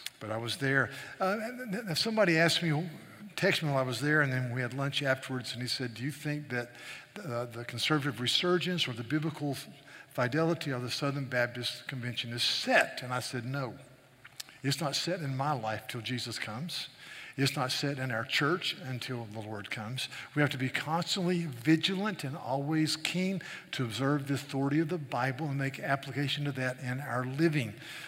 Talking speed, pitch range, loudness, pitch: 195 wpm, 125-155 Hz, -32 LUFS, 135 Hz